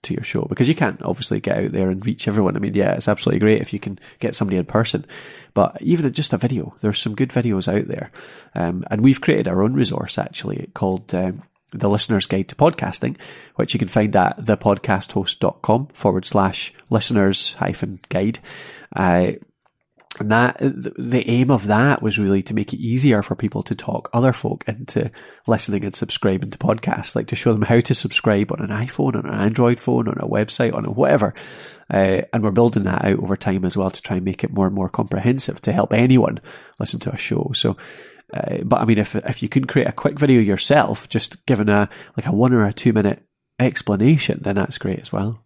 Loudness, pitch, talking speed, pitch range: -19 LUFS, 110 Hz, 215 wpm, 100-125 Hz